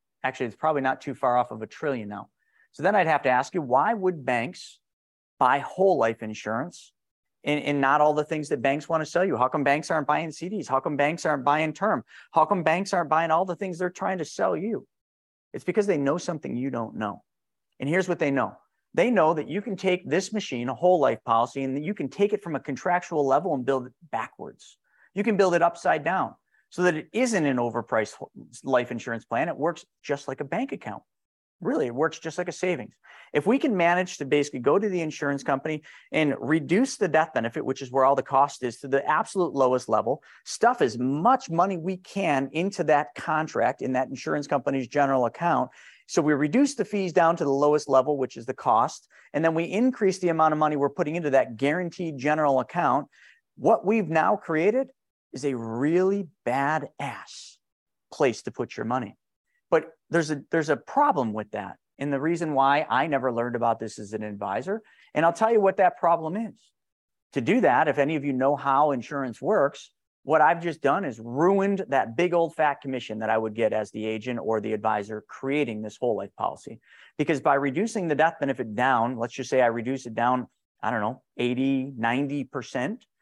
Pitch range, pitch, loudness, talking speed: 130-175 Hz, 150 Hz, -25 LUFS, 215 wpm